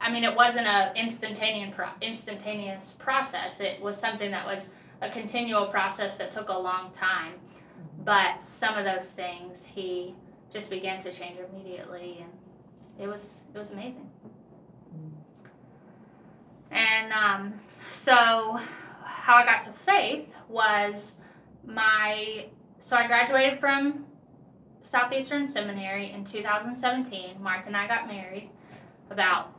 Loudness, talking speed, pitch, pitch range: -26 LUFS, 130 wpm, 205 Hz, 190-230 Hz